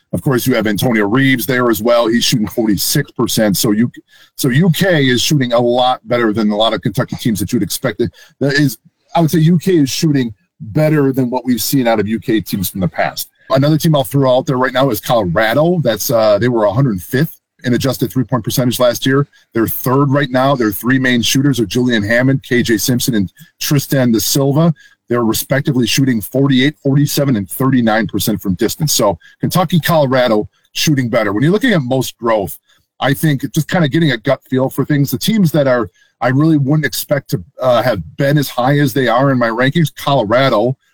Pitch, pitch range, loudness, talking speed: 130 Hz, 120-145 Hz, -14 LUFS, 210 wpm